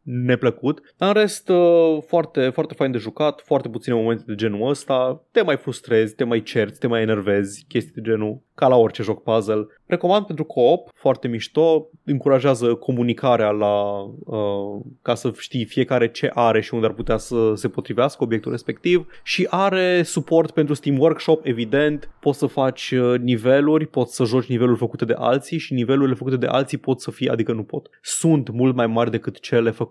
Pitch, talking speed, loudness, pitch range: 130 Hz, 185 wpm, -20 LUFS, 115-150 Hz